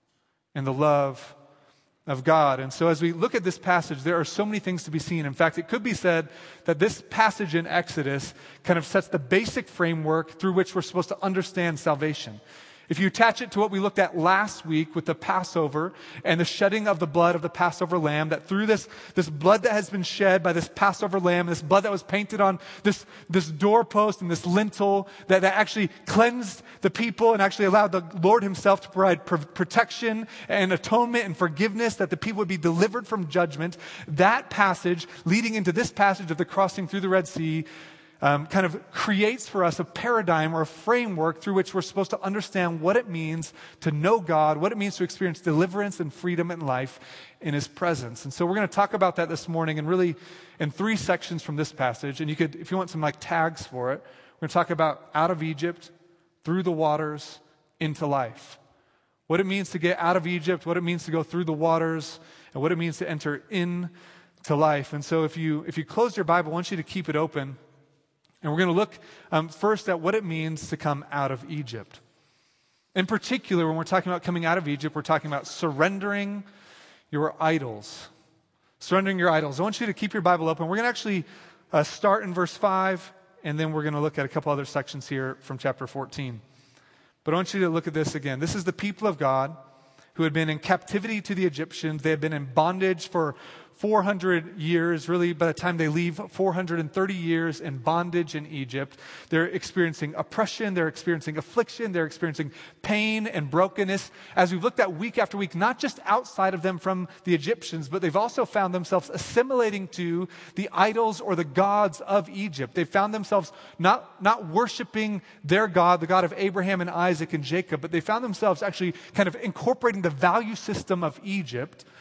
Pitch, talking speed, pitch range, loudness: 175 Hz, 210 wpm, 160-195 Hz, -25 LUFS